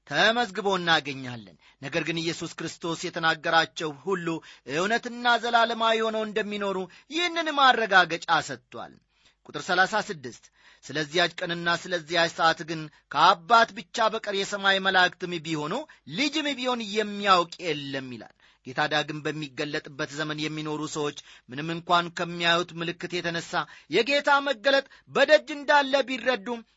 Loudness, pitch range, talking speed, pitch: -25 LUFS, 155-225 Hz, 110 wpm, 175 Hz